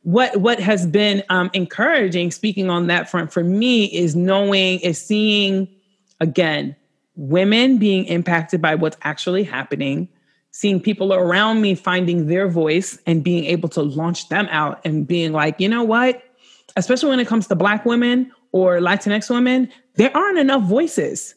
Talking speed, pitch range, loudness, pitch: 165 wpm, 170-215 Hz, -18 LUFS, 190 Hz